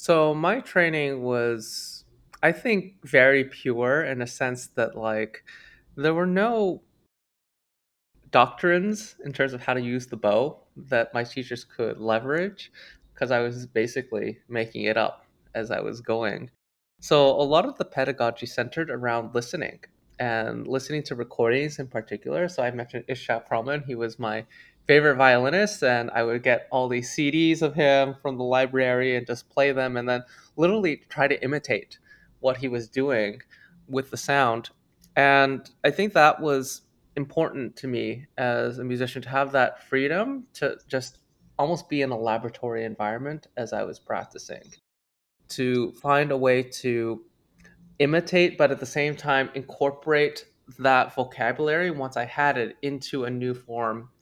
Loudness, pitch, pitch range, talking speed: -25 LUFS, 130 Hz, 120-145 Hz, 160 wpm